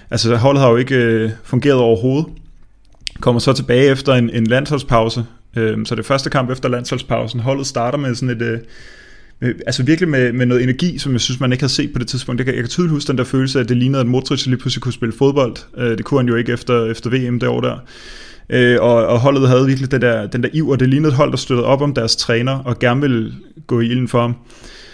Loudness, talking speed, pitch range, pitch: -16 LUFS, 250 wpm, 120-135 Hz, 125 Hz